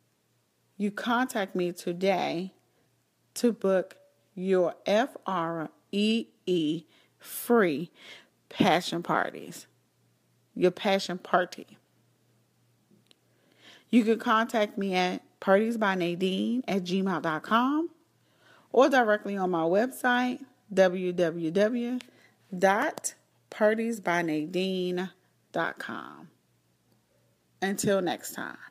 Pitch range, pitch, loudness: 180-225 Hz, 195 Hz, -28 LUFS